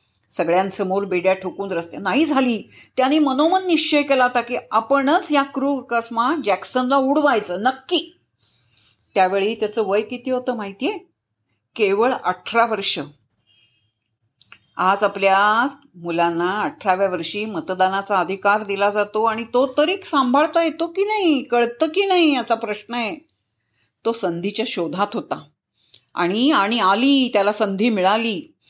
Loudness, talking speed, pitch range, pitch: -19 LUFS, 125 wpm, 190-275 Hz, 220 Hz